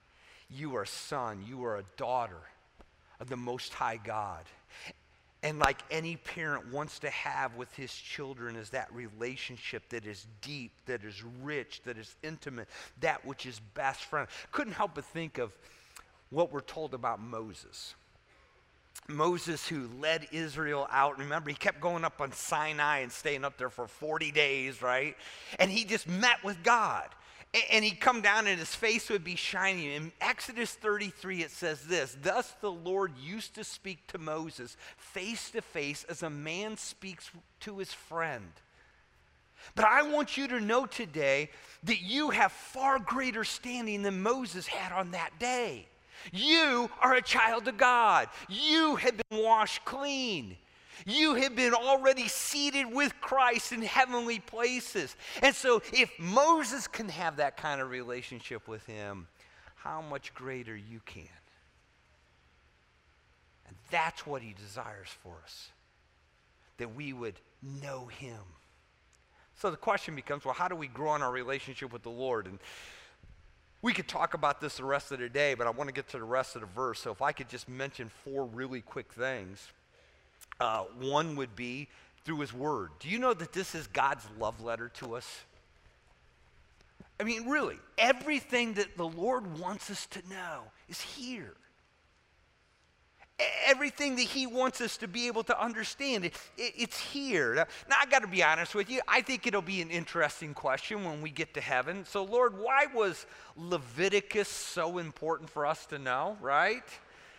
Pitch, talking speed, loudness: 160 Hz, 170 wpm, -32 LUFS